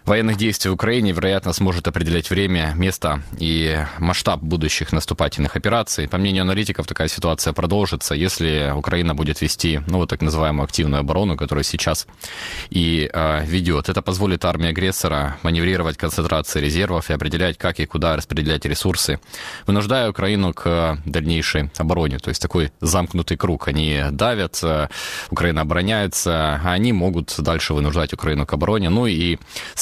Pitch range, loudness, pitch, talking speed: 80-95 Hz, -20 LUFS, 85 Hz, 145 wpm